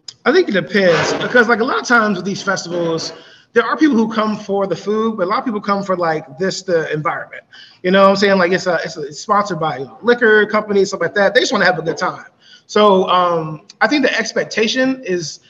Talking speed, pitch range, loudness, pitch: 250 wpm, 175-220 Hz, -15 LUFS, 195 Hz